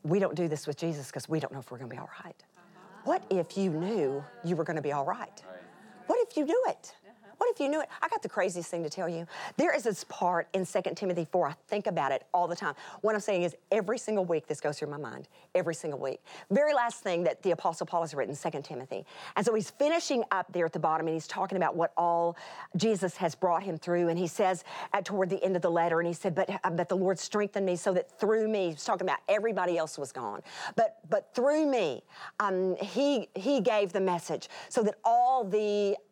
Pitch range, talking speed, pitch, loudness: 170-210 Hz, 255 wpm, 185 Hz, -31 LUFS